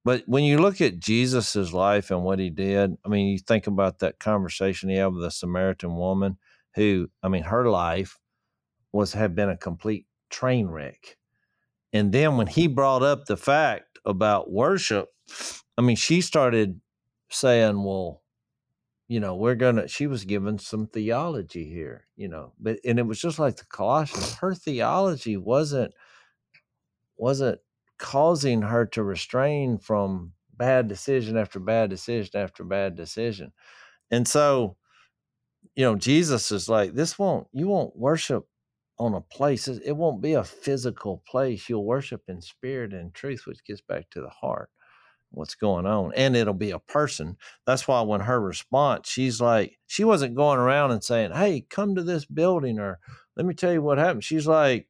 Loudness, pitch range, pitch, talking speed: -25 LUFS, 100-135 Hz, 115 Hz, 170 wpm